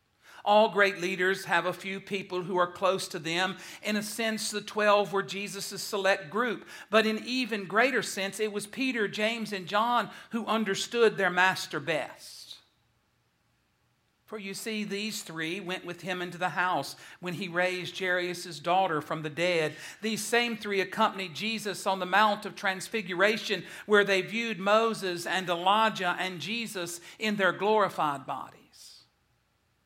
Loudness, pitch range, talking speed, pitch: -29 LUFS, 180-215 Hz, 155 wpm, 195 Hz